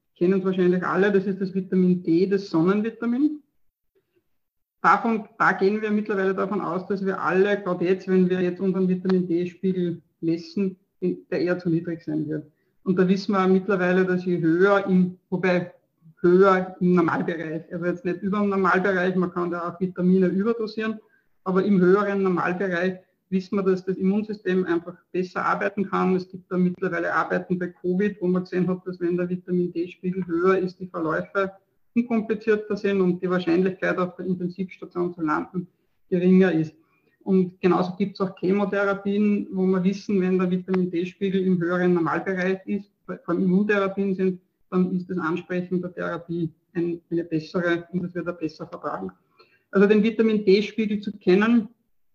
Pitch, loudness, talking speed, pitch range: 185 Hz, -24 LUFS, 170 wpm, 175-195 Hz